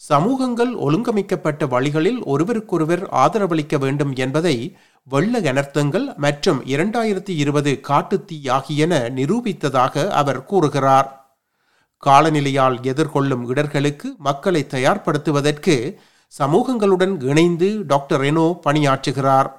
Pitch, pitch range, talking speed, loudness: 150 Hz, 140-180 Hz, 85 wpm, -18 LUFS